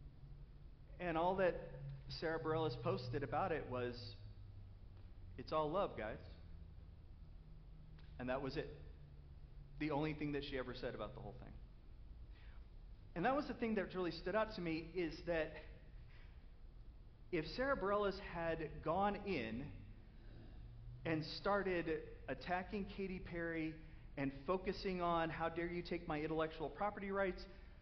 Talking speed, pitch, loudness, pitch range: 135 wpm, 155 Hz, -43 LUFS, 110-180 Hz